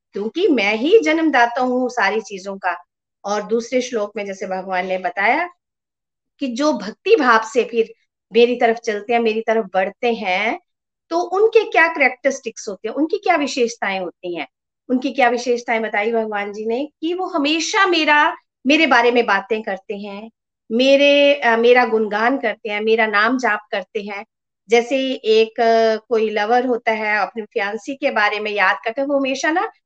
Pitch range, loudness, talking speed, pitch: 210-275 Hz, -18 LUFS, 170 wpm, 235 Hz